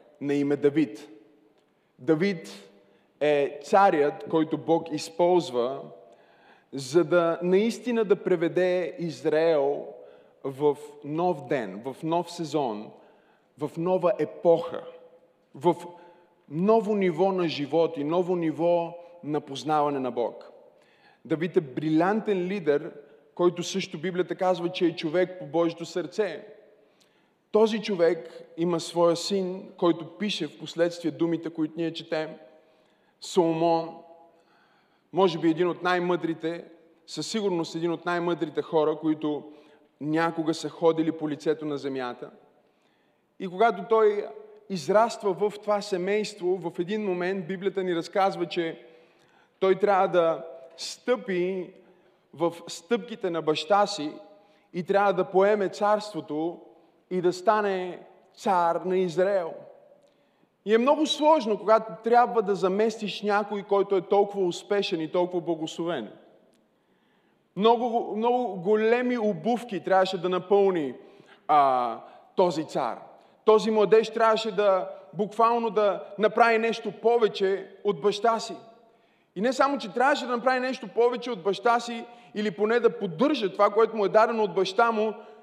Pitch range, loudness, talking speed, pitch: 165-210 Hz, -26 LUFS, 125 wpm, 180 Hz